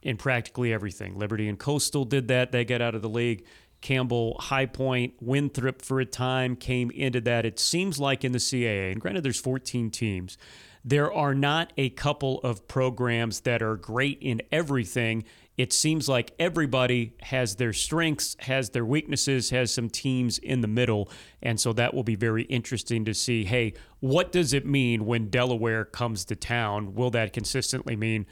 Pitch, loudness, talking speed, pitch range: 125 Hz, -27 LUFS, 180 wpm, 115-130 Hz